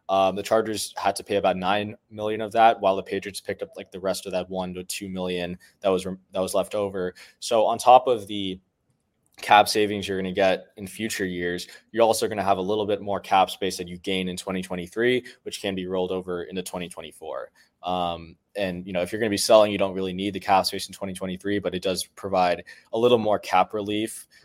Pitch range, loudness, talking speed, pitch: 90-105 Hz, -24 LUFS, 240 wpm, 95 Hz